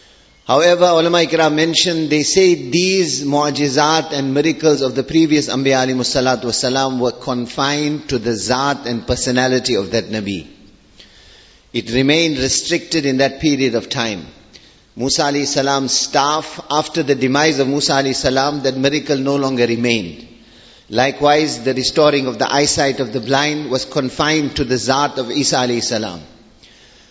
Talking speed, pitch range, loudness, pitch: 145 wpm, 125-150 Hz, -16 LUFS, 135 Hz